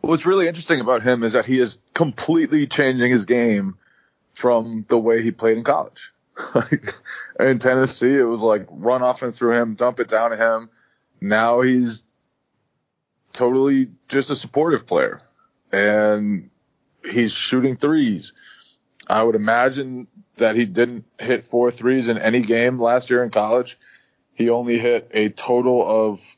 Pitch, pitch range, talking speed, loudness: 120 Hz, 115-130 Hz, 155 wpm, -19 LUFS